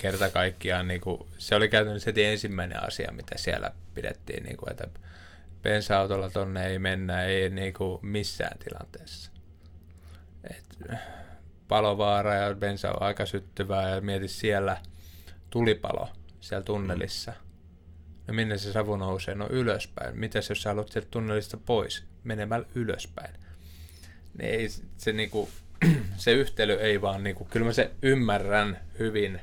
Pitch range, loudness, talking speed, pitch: 85-105 Hz, -29 LUFS, 140 wpm, 95 Hz